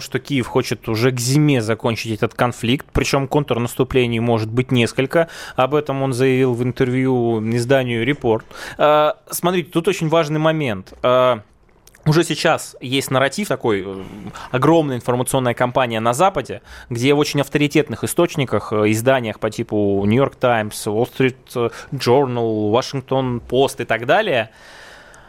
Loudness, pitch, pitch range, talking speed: -18 LUFS, 130 Hz, 115-140 Hz, 130 wpm